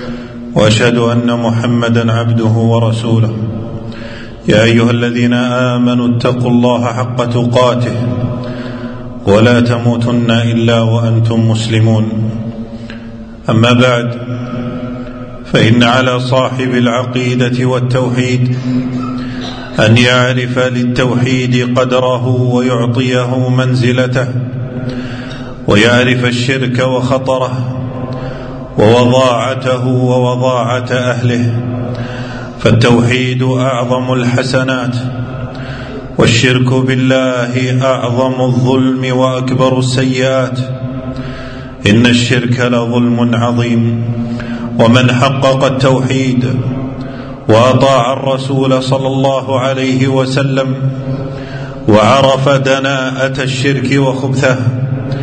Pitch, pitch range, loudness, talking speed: 125 Hz, 120-130 Hz, -12 LUFS, 70 wpm